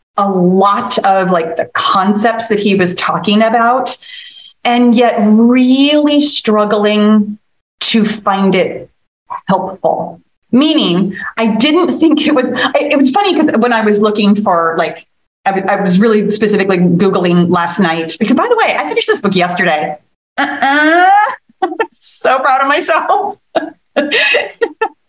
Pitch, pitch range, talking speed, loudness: 220 Hz, 195-295 Hz, 140 wpm, -11 LUFS